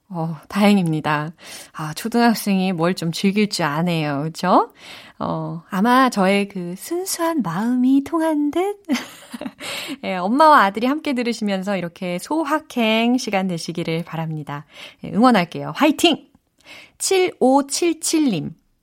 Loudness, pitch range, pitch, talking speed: -19 LUFS, 175-280 Hz, 215 Hz, 250 characters per minute